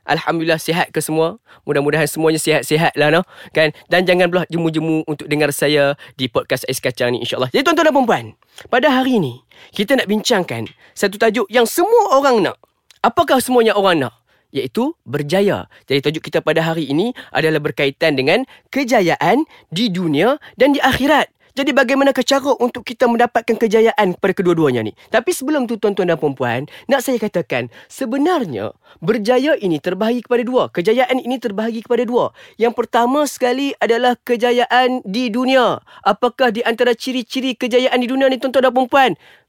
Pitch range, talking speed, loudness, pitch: 160-255 Hz, 165 wpm, -16 LUFS, 230 Hz